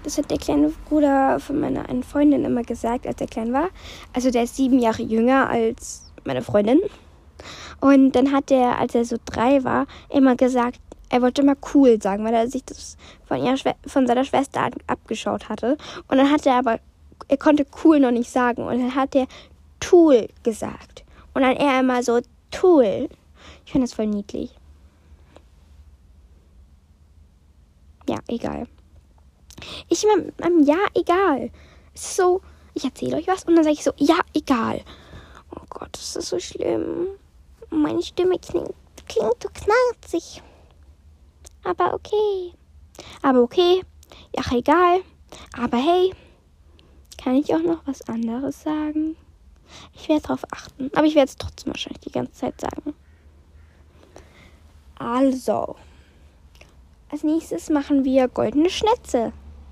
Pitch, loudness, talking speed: 260 Hz, -21 LUFS, 145 wpm